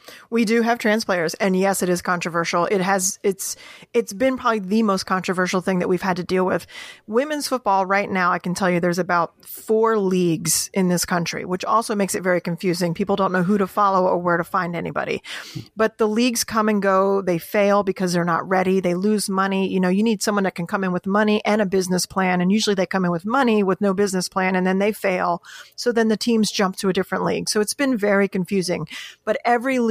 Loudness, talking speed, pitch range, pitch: -20 LUFS, 240 wpm, 180-215 Hz, 195 Hz